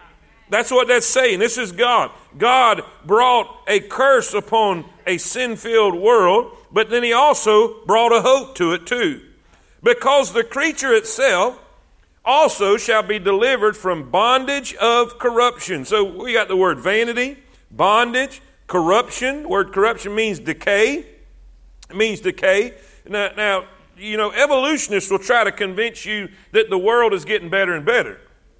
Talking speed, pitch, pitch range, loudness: 150 wpm, 230 Hz, 205-270 Hz, -17 LUFS